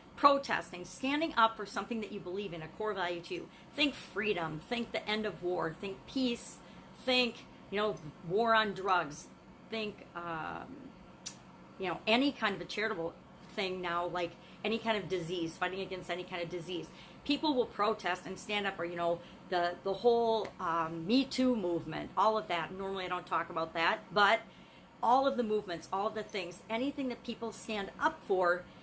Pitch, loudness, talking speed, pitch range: 195 Hz, -34 LUFS, 185 wpm, 175-225 Hz